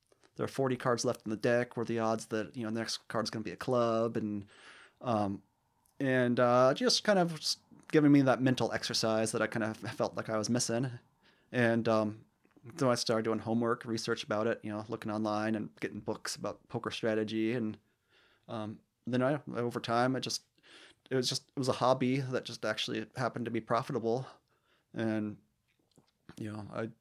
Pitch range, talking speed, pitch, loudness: 110-125 Hz, 205 wpm, 115 Hz, -33 LUFS